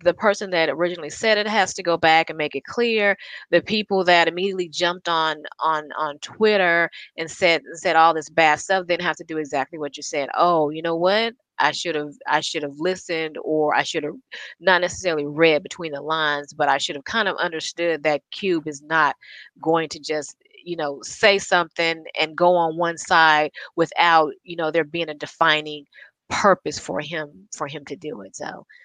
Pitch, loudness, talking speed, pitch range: 165 Hz, -21 LUFS, 205 wpm, 155-175 Hz